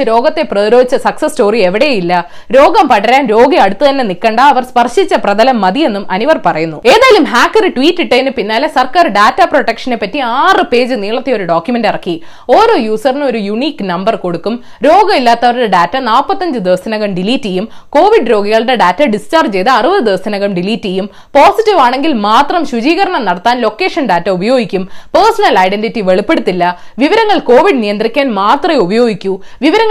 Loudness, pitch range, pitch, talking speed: -10 LUFS, 205-305 Hz, 240 Hz, 105 wpm